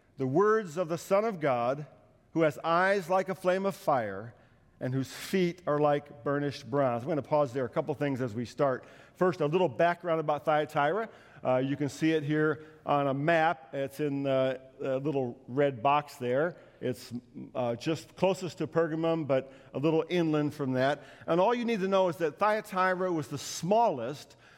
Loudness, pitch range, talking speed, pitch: -30 LUFS, 135-170 Hz, 195 wpm, 150 Hz